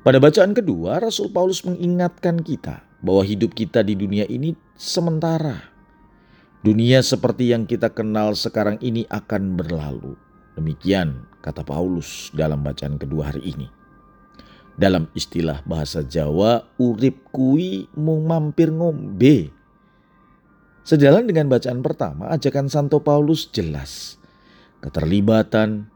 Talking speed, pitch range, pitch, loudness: 115 wpm, 95-155 Hz, 115 Hz, -20 LUFS